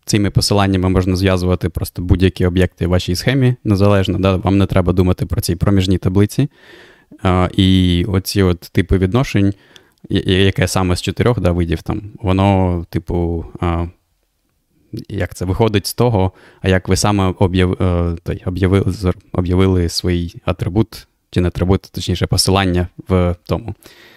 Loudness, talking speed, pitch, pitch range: -16 LUFS, 145 wpm, 95 Hz, 90-100 Hz